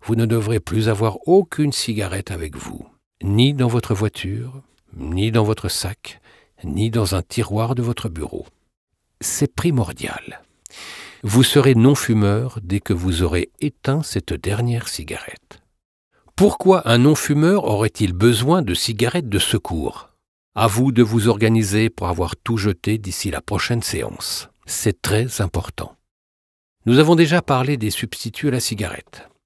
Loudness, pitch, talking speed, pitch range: -19 LUFS, 110 Hz, 145 wpm, 100-125 Hz